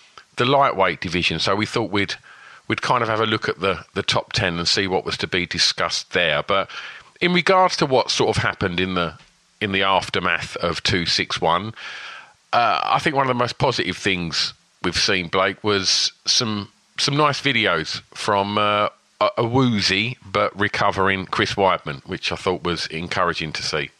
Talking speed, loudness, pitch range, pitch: 185 wpm, -20 LUFS, 90-110 Hz, 100 Hz